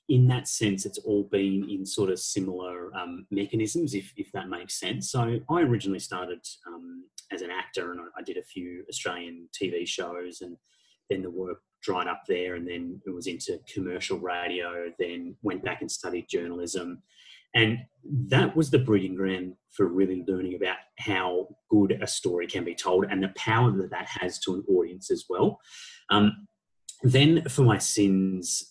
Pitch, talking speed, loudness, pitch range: 100 Hz, 180 wpm, -28 LUFS, 90-140 Hz